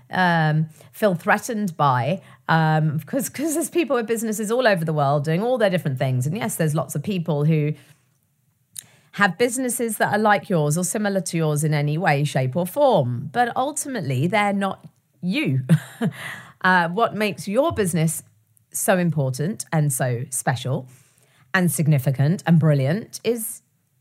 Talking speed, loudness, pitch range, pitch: 155 wpm, -21 LUFS, 145-205 Hz, 160 Hz